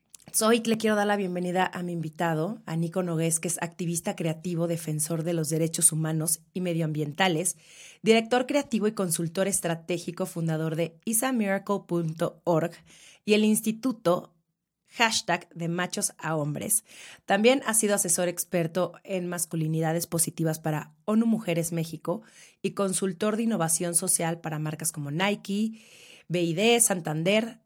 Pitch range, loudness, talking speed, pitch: 165-205 Hz, -27 LUFS, 135 wpm, 175 Hz